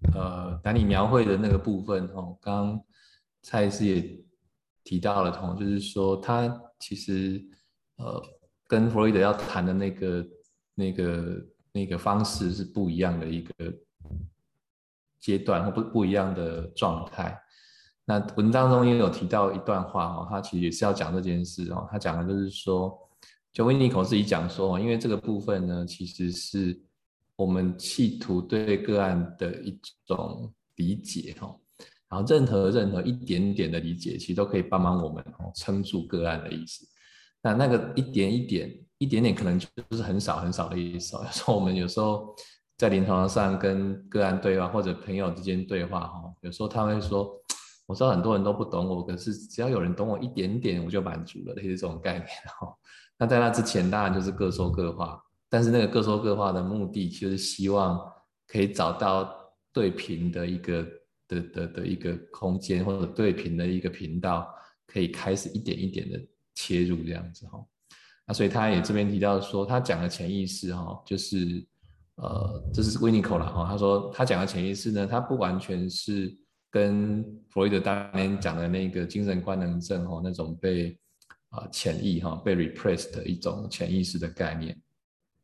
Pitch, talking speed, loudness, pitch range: 95 Hz, 275 characters per minute, -28 LUFS, 90-105 Hz